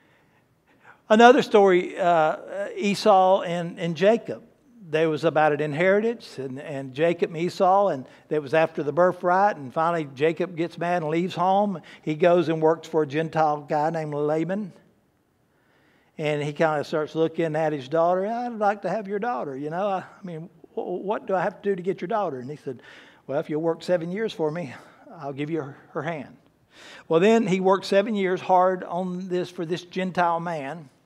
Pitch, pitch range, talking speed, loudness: 170 Hz, 155-190 Hz, 190 wpm, -23 LUFS